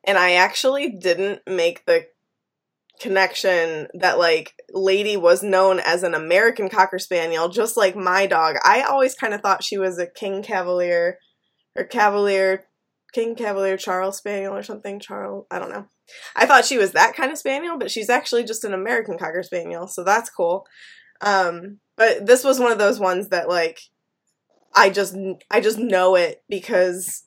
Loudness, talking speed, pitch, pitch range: -19 LUFS, 175 wpm, 195 Hz, 185-230 Hz